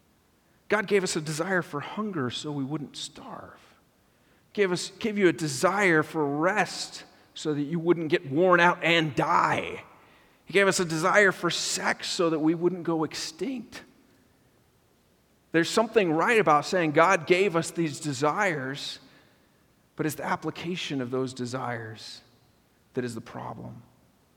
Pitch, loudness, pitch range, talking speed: 165 Hz, -26 LUFS, 150-185 Hz, 155 wpm